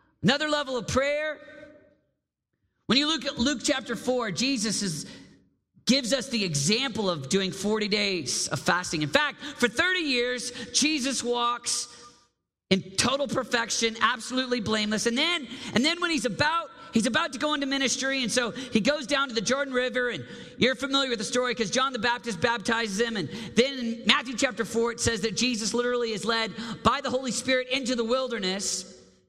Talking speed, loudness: 180 wpm, -26 LUFS